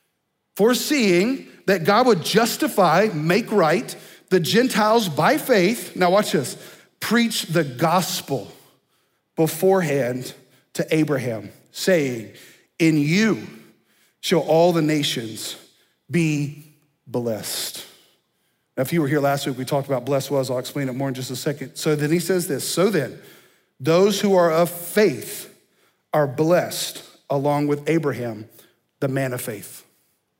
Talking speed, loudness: 140 wpm, -21 LUFS